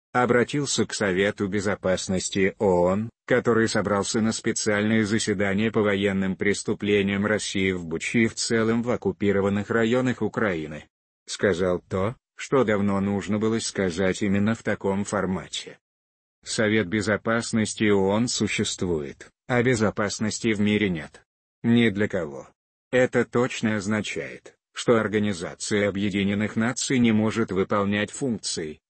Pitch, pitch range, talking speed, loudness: 105 Hz, 100-115 Hz, 120 wpm, -24 LUFS